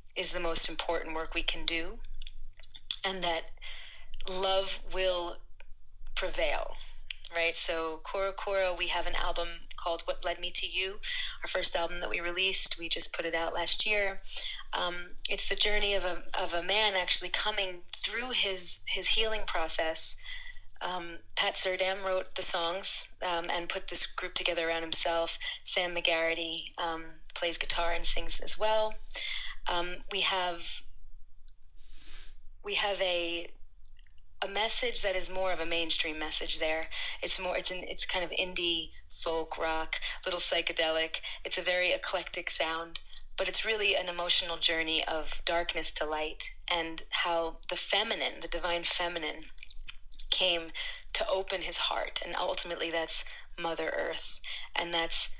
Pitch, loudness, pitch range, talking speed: 175 Hz, -29 LUFS, 165-190 Hz, 155 wpm